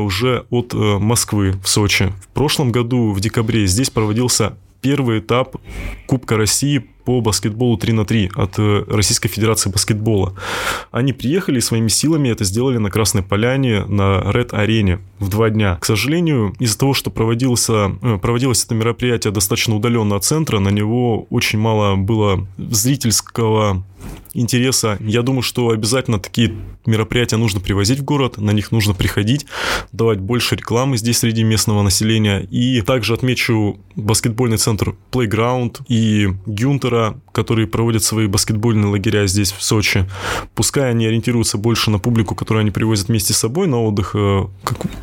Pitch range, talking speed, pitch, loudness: 105-120 Hz, 150 wpm, 110 Hz, -16 LUFS